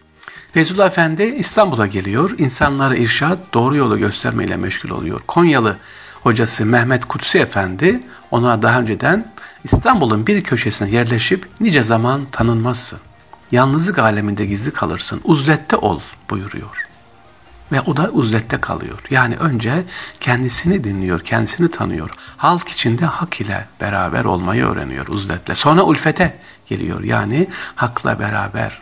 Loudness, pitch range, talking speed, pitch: -16 LUFS, 110-165 Hz, 120 wpm, 125 Hz